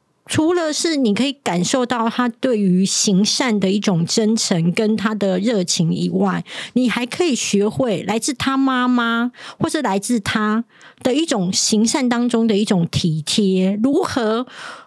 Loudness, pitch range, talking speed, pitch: -18 LUFS, 195-250 Hz, 225 characters per minute, 225 Hz